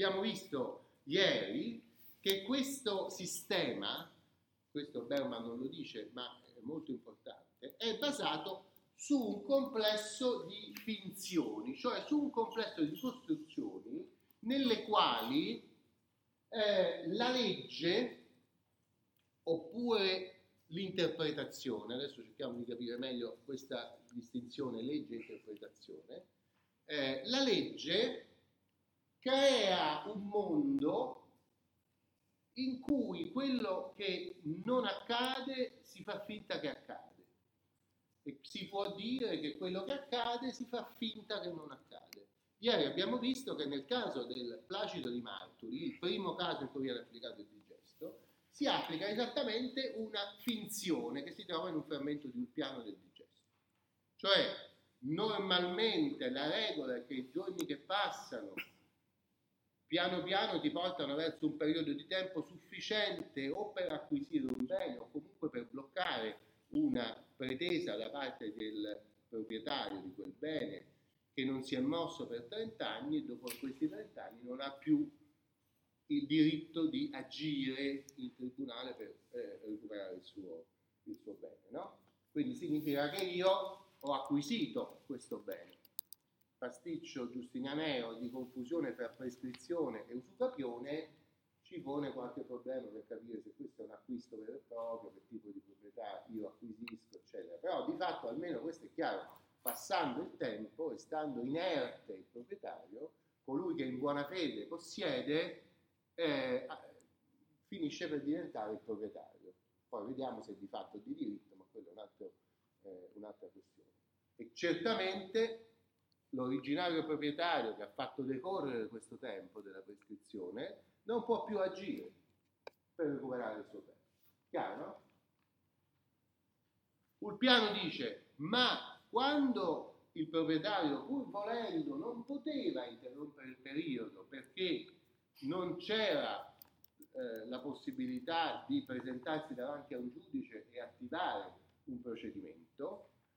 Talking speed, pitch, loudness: 130 wpm, 200 Hz, -39 LUFS